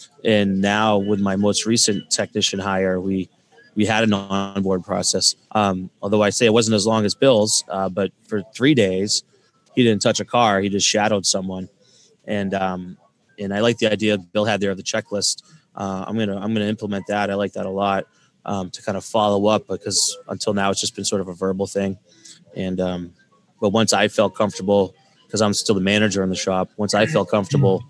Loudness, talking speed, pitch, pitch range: -20 LUFS, 215 wpm, 100 Hz, 95-105 Hz